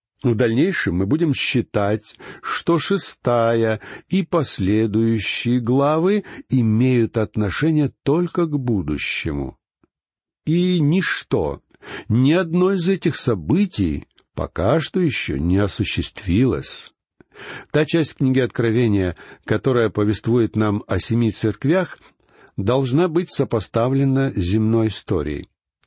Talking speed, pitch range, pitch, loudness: 100 wpm, 105-155 Hz, 120 Hz, -20 LUFS